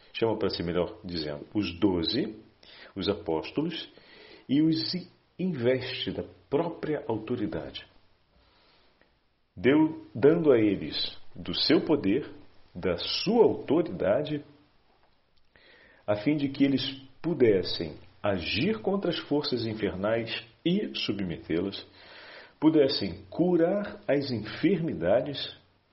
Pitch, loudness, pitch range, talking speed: 125 Hz, -28 LUFS, 100-155 Hz, 95 wpm